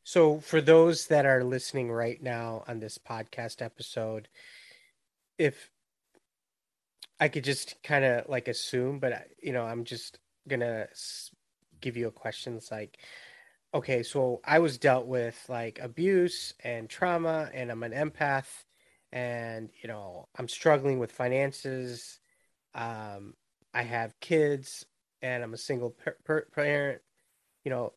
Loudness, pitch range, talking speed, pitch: -30 LUFS, 115-145 Hz, 145 wpm, 125 Hz